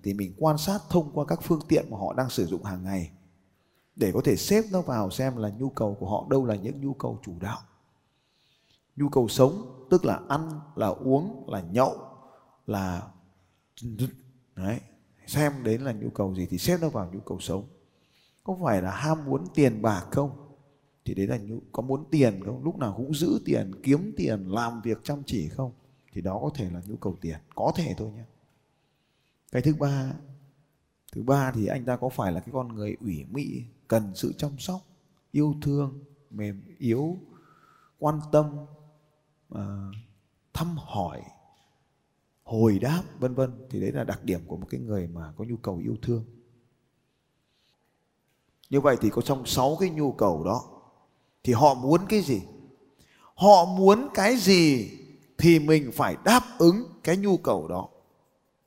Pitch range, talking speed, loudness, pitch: 105-150 Hz, 180 wpm, -26 LUFS, 130 Hz